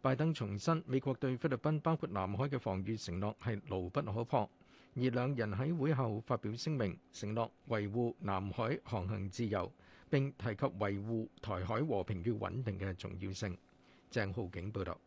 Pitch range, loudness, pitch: 100-130 Hz, -38 LUFS, 110 Hz